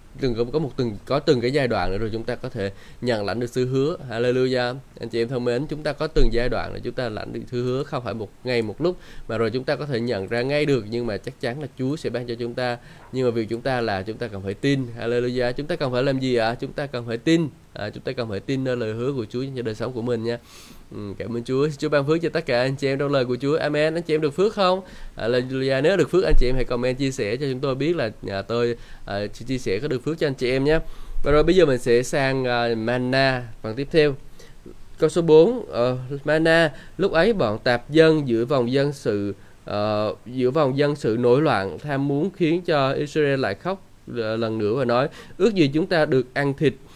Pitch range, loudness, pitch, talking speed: 120-145 Hz, -23 LUFS, 125 Hz, 270 wpm